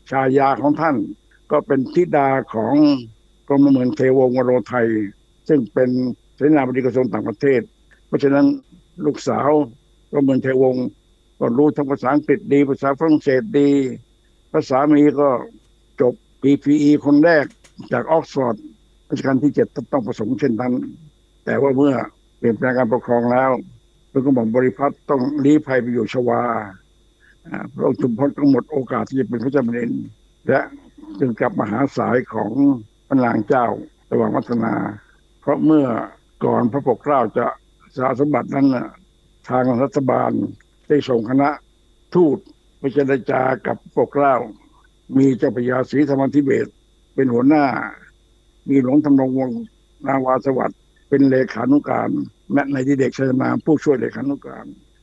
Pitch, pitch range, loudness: 135 Hz, 125-145 Hz, -18 LUFS